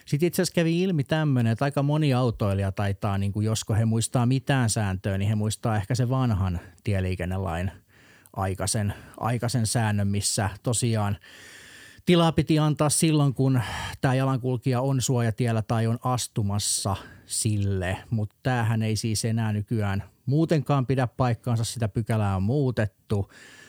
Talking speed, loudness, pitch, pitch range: 140 wpm, -25 LUFS, 115 Hz, 105-130 Hz